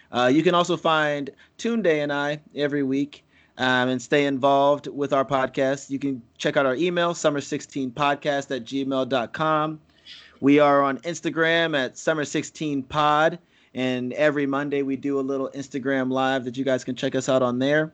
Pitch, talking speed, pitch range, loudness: 140 Hz, 170 wpm, 135-150 Hz, -23 LUFS